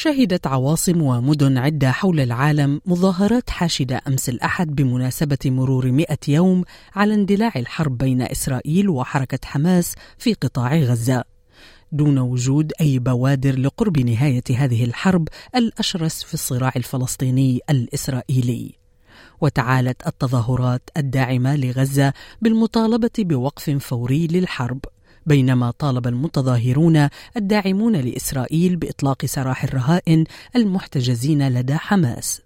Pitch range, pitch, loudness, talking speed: 130-165 Hz, 140 Hz, -19 LUFS, 105 wpm